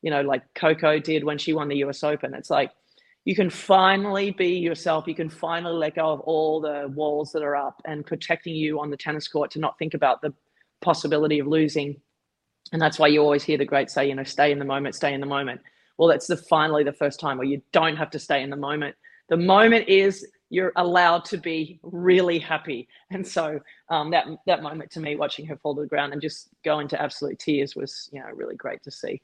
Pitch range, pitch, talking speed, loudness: 145-170 Hz, 155 Hz, 240 wpm, -23 LUFS